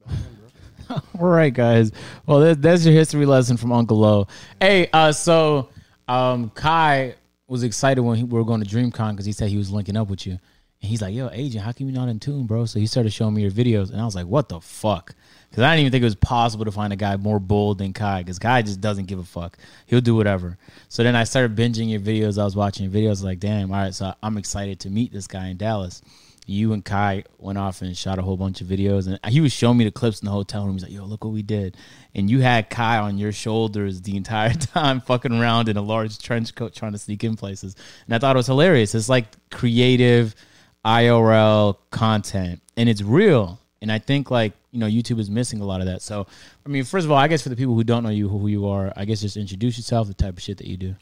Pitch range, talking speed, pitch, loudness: 100-120 Hz, 260 wpm, 110 Hz, -20 LUFS